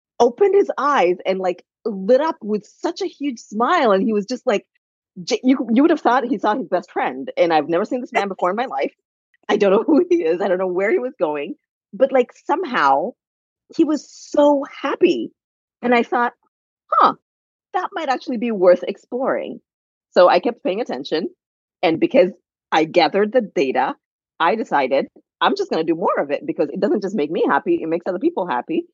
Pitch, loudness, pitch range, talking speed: 250 Hz, -19 LUFS, 190-310 Hz, 205 wpm